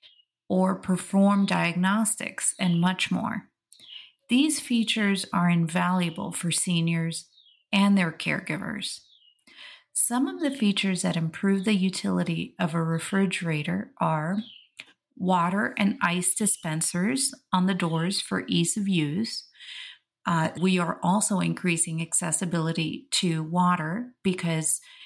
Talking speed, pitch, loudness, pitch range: 115 wpm, 185 Hz, -25 LUFS, 170-205 Hz